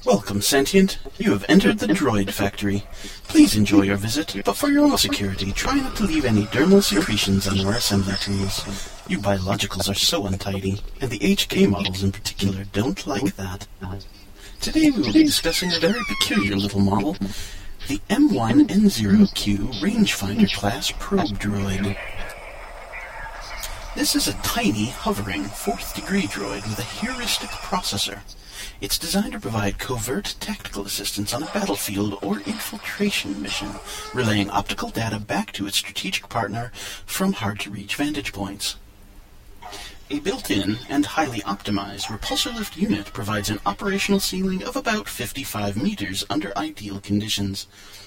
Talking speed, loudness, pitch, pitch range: 140 wpm, -22 LUFS, 100 Hz, 100-105 Hz